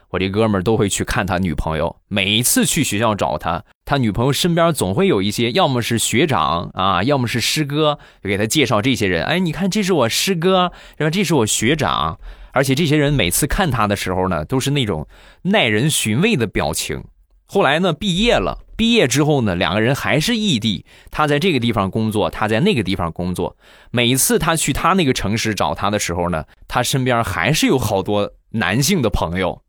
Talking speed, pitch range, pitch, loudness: 310 characters per minute, 100-150 Hz, 120 Hz, -17 LUFS